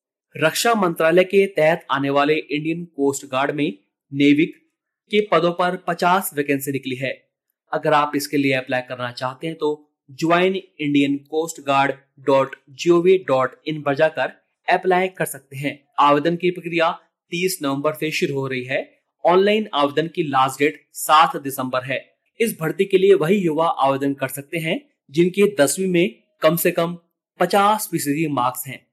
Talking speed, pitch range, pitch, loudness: 165 wpm, 140-180 Hz, 155 Hz, -20 LUFS